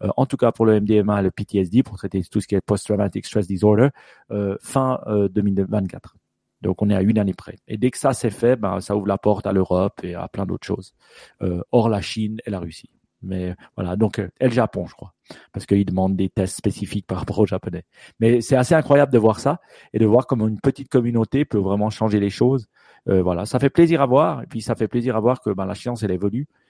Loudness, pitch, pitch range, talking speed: -21 LUFS, 105 Hz, 100-120 Hz, 250 wpm